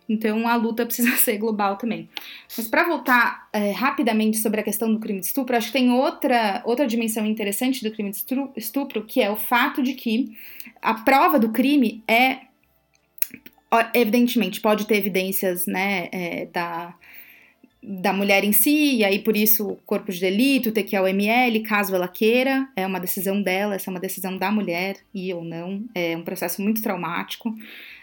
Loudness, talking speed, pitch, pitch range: -22 LUFS, 180 wpm, 220 Hz, 195-245 Hz